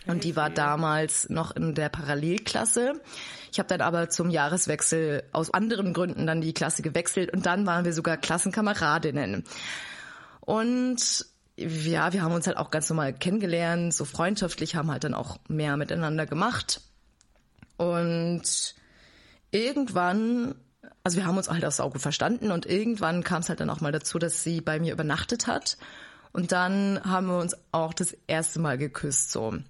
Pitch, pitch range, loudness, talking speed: 170 Hz, 155-185 Hz, -27 LUFS, 170 wpm